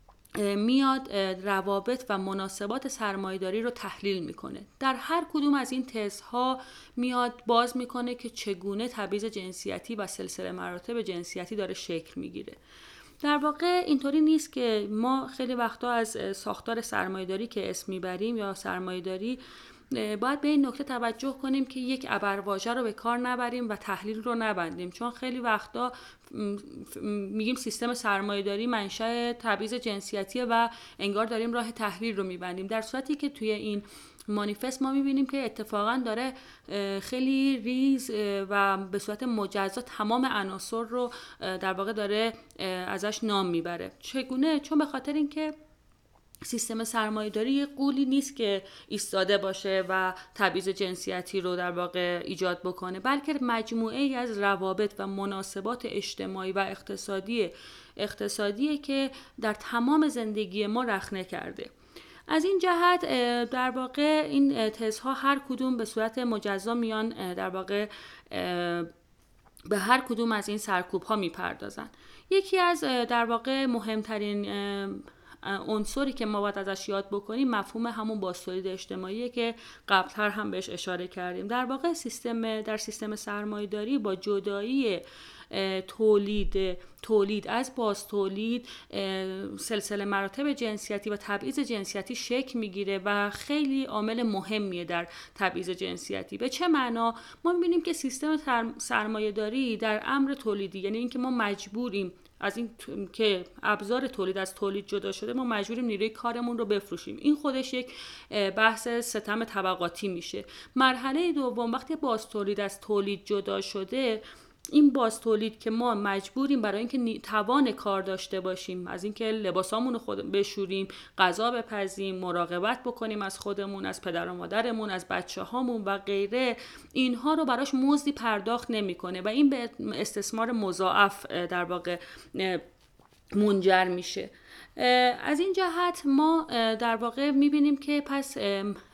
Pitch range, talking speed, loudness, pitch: 200-250 Hz, 140 wpm, -30 LUFS, 220 Hz